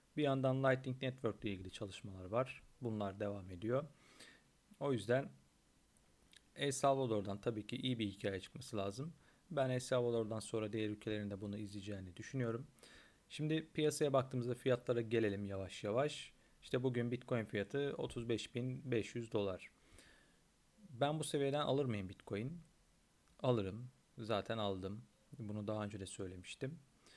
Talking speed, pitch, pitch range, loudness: 125 wpm, 115 Hz, 100-130 Hz, -41 LUFS